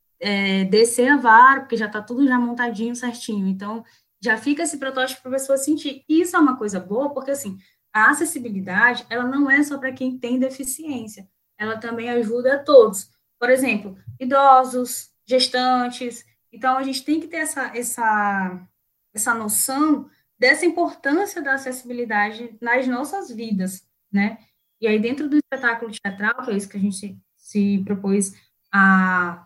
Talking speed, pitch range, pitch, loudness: 160 wpm, 215-270 Hz, 245 Hz, -20 LUFS